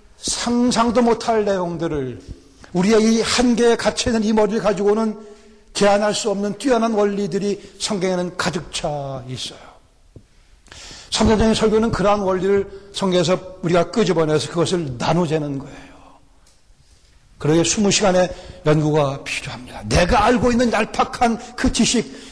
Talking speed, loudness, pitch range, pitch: 300 characters per minute, -19 LUFS, 165-225 Hz, 200 Hz